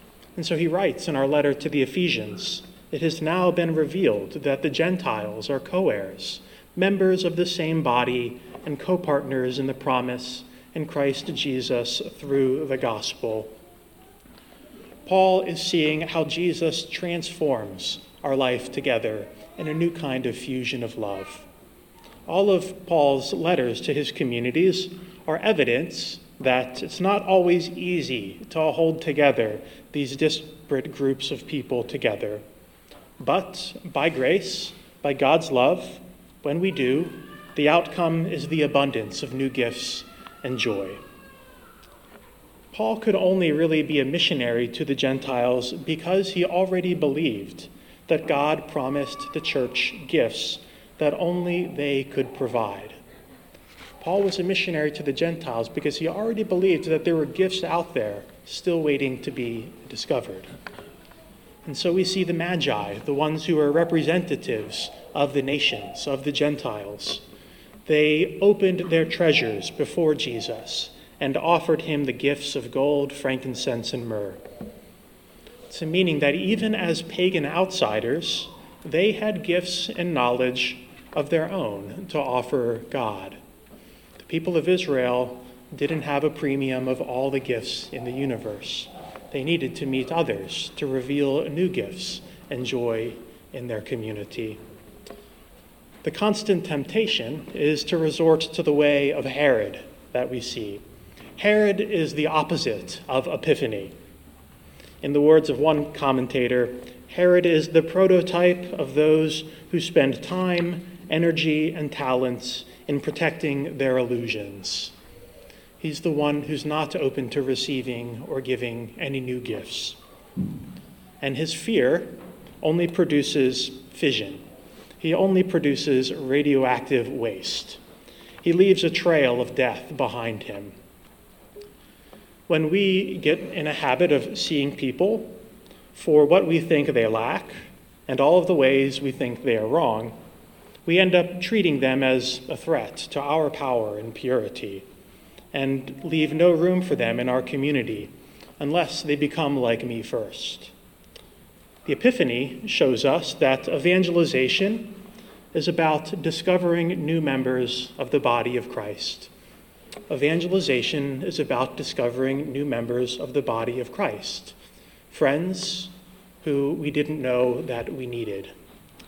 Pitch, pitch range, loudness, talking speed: 150 Hz, 130-175 Hz, -24 LUFS, 135 wpm